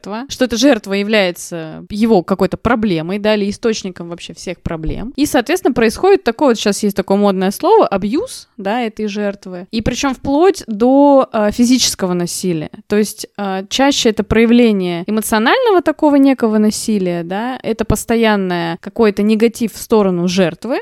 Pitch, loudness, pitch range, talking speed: 215 Hz, -14 LUFS, 195-250 Hz, 150 wpm